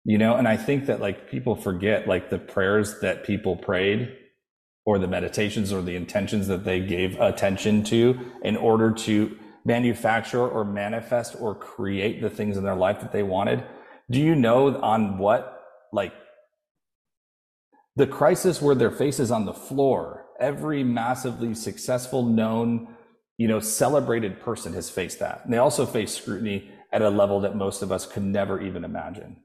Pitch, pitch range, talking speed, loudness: 110 Hz, 100-125 Hz, 170 wpm, -24 LUFS